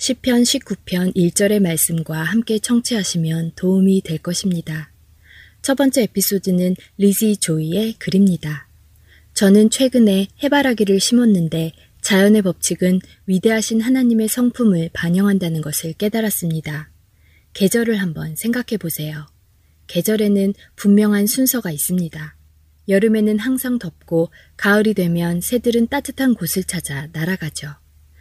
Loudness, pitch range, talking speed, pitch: -17 LUFS, 160-220 Hz, 285 characters per minute, 190 Hz